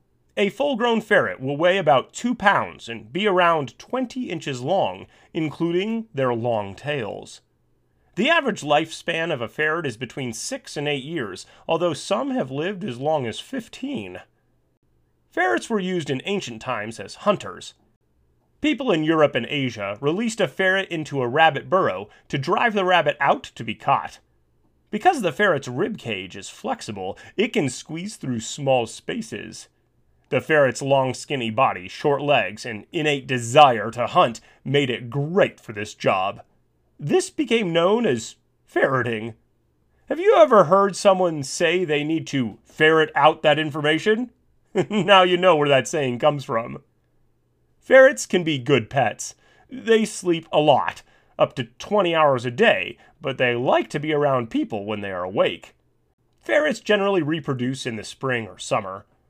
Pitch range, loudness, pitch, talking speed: 130-200 Hz, -21 LUFS, 155 Hz, 160 wpm